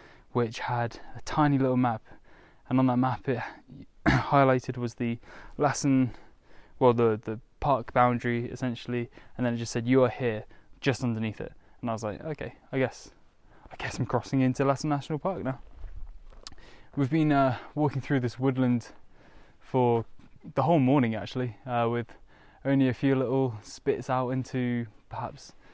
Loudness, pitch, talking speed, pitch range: -28 LUFS, 125 Hz, 165 wpm, 120-135 Hz